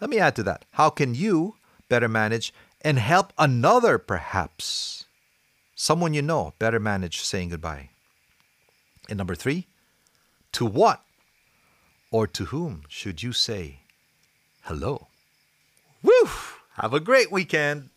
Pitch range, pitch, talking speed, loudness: 100-155 Hz, 120 Hz, 125 wpm, -24 LUFS